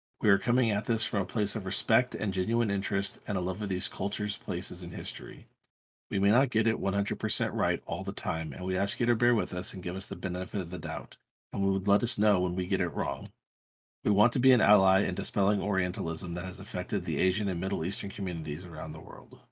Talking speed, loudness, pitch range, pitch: 255 wpm, -30 LUFS, 90-105 Hz, 100 Hz